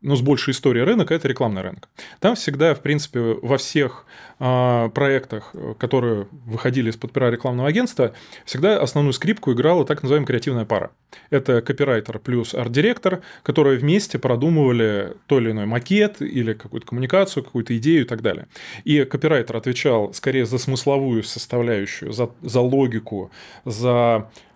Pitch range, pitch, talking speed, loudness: 120-145 Hz, 130 Hz, 145 wpm, -20 LUFS